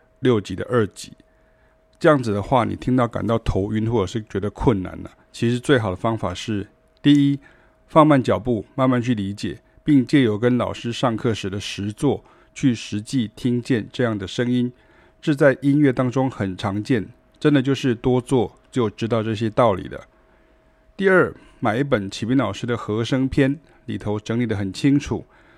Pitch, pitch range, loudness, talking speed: 120 Hz, 105-135 Hz, -21 LUFS, 260 characters per minute